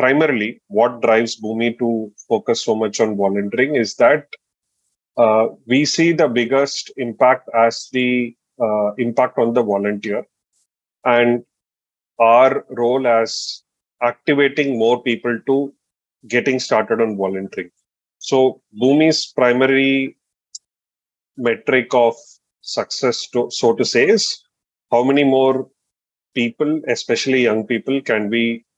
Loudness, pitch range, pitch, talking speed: -17 LUFS, 110-130 Hz, 120 Hz, 120 wpm